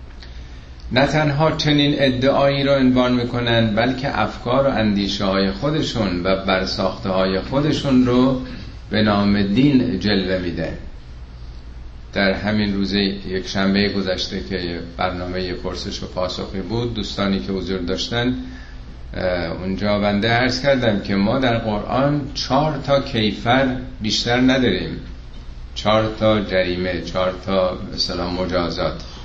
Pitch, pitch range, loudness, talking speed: 100 Hz, 90-125 Hz, -19 LUFS, 120 wpm